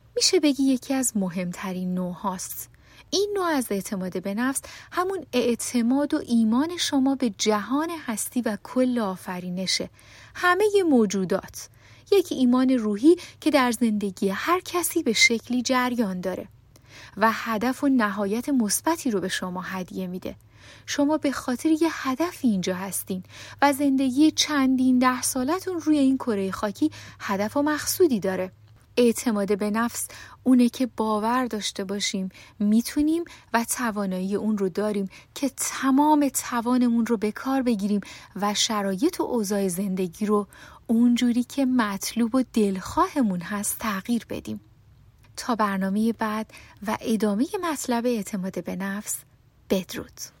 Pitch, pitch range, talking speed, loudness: 230 Hz, 195-270 Hz, 135 wpm, -24 LUFS